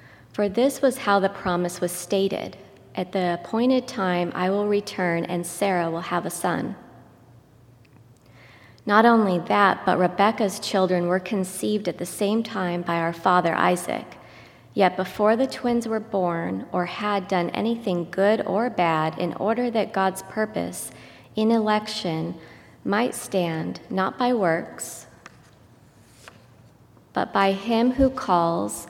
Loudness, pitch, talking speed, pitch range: -23 LUFS, 185 Hz, 140 wpm, 170-210 Hz